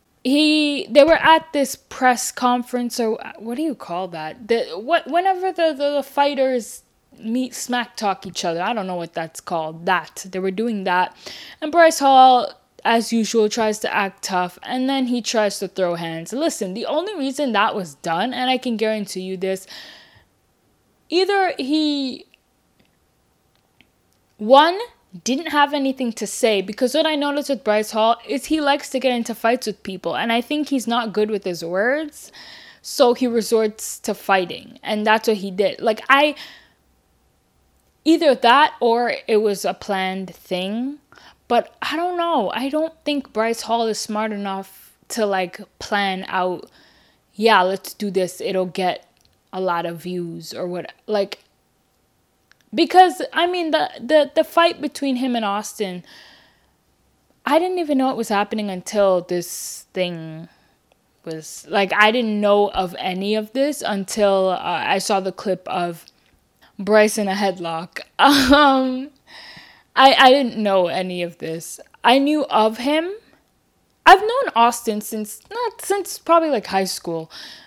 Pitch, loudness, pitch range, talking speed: 225 Hz, -19 LUFS, 195-280 Hz, 160 wpm